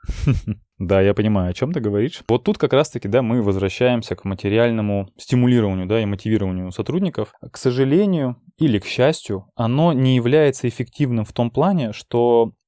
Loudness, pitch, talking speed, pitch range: -19 LUFS, 120 Hz, 160 wpm, 105-130 Hz